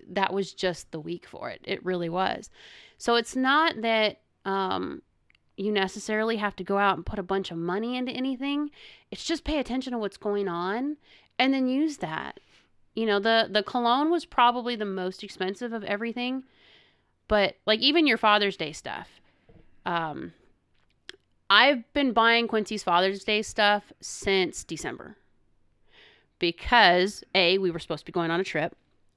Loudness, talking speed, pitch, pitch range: -26 LUFS, 165 wpm, 210 Hz, 190-245 Hz